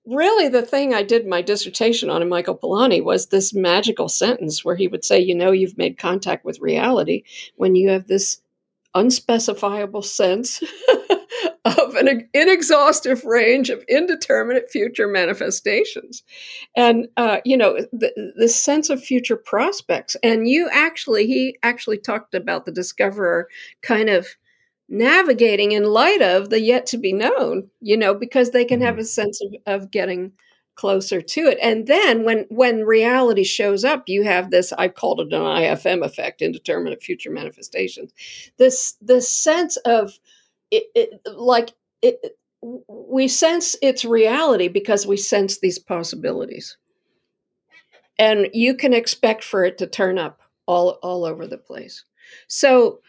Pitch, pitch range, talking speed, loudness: 230 Hz, 200-275 Hz, 155 wpm, -18 LUFS